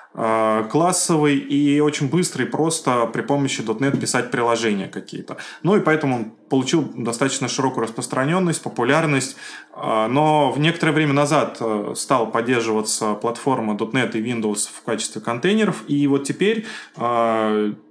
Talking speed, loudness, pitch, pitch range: 125 wpm, -20 LUFS, 130 Hz, 115-150 Hz